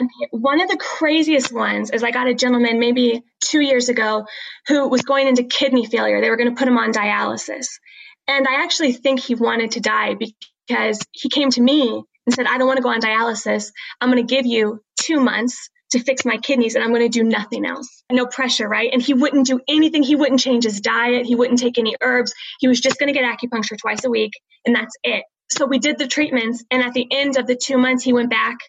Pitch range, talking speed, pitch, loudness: 230-270 Hz, 240 wpm, 250 Hz, -18 LUFS